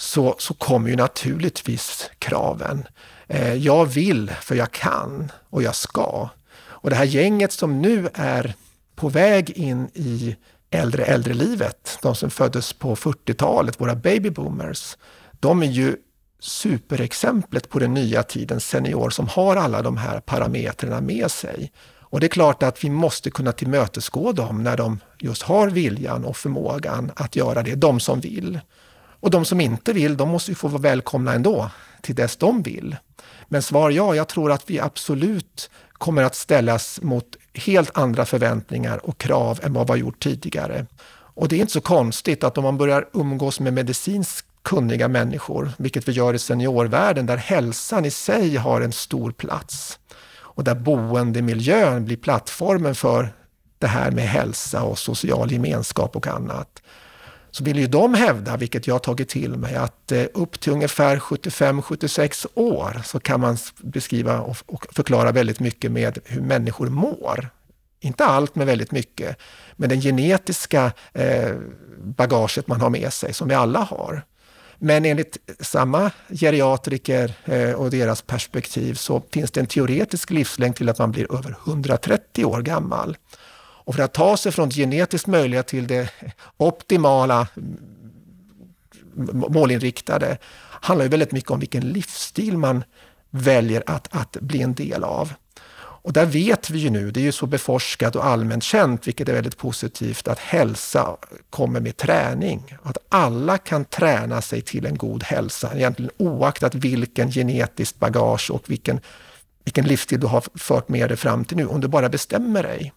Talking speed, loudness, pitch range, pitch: 165 wpm, -21 LUFS, 120-160 Hz, 135 Hz